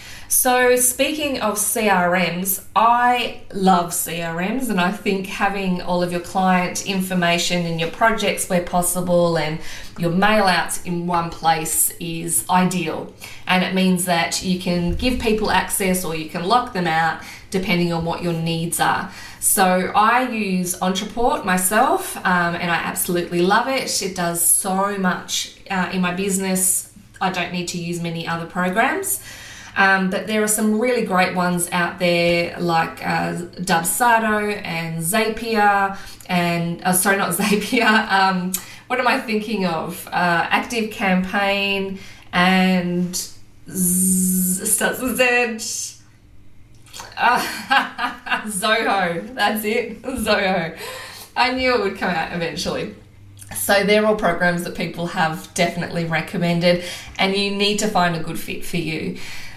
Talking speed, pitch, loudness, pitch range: 145 wpm, 185 Hz, -19 LUFS, 170-210 Hz